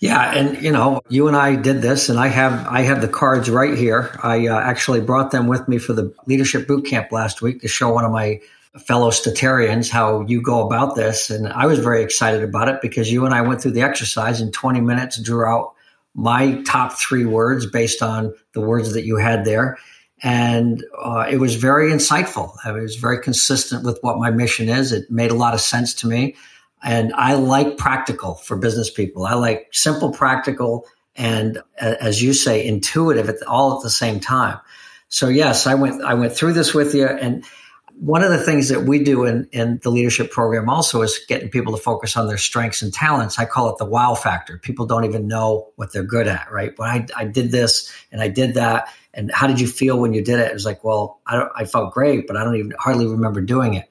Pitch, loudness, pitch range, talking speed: 120 Hz, -18 LUFS, 115-130 Hz, 230 wpm